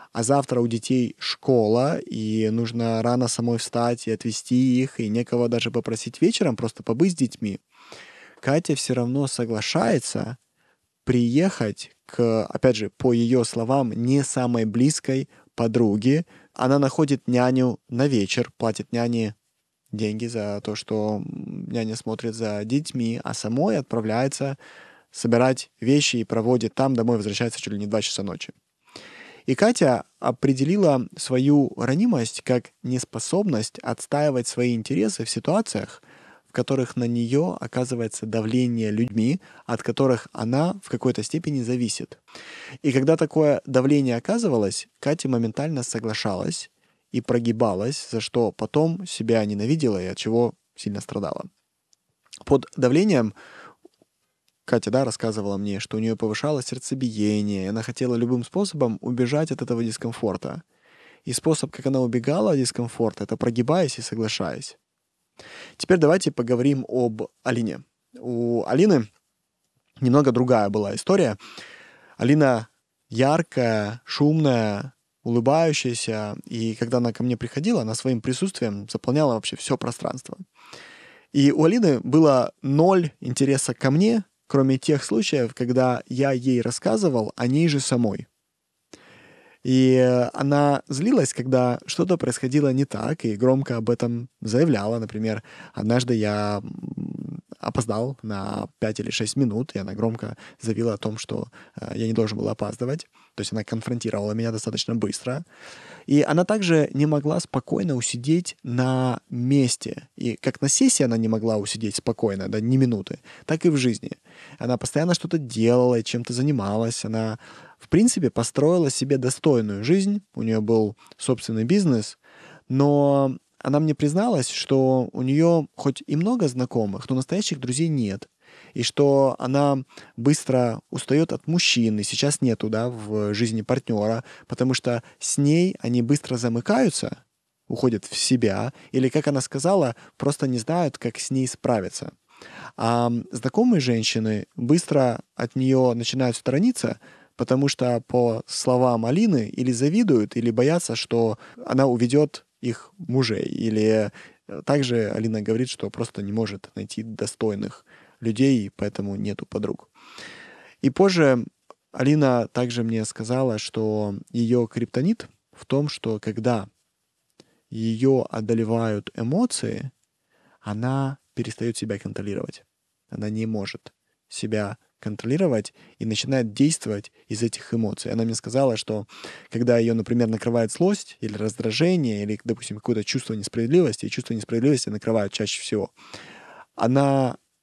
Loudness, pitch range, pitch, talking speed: -23 LUFS, 115-140 Hz, 120 Hz, 135 wpm